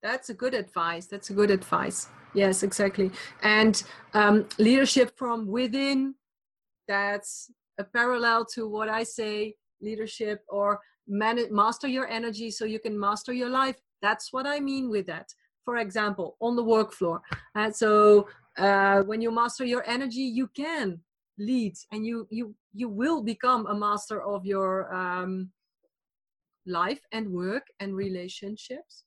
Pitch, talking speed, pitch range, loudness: 215 Hz, 150 wpm, 200-240 Hz, -27 LUFS